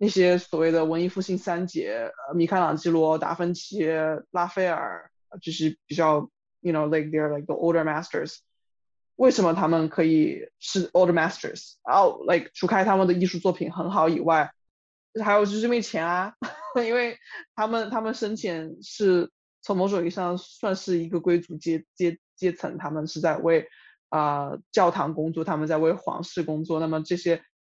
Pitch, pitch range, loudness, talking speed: 175 Hz, 160-195 Hz, -25 LUFS, 345 characters per minute